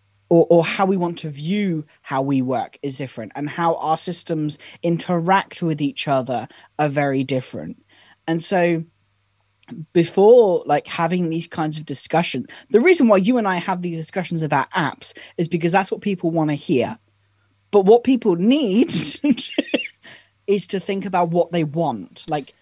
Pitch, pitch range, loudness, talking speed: 165 Hz, 145-190 Hz, -20 LUFS, 165 wpm